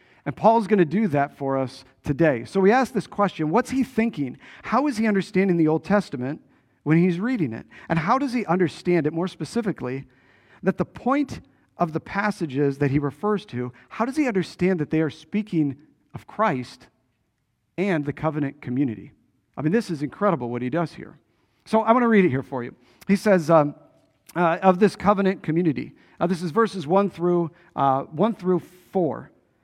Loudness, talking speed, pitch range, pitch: -23 LUFS, 195 wpm, 140-200 Hz, 170 Hz